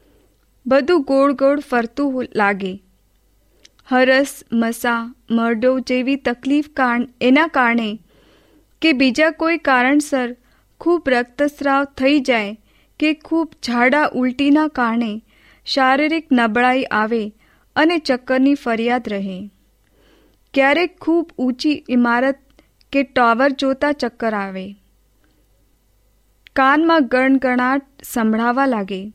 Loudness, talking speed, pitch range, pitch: -17 LUFS, 95 wpm, 230-280 Hz, 255 Hz